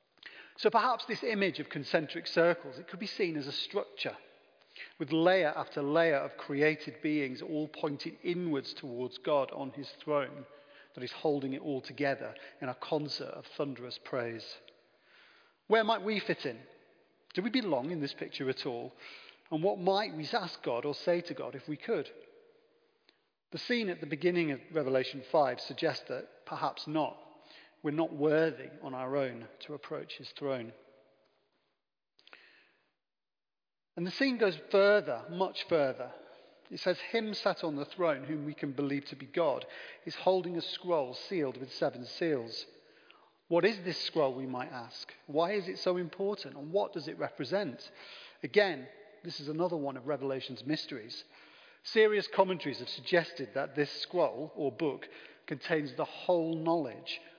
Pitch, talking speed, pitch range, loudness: 160 Hz, 165 wpm, 140-190 Hz, -34 LUFS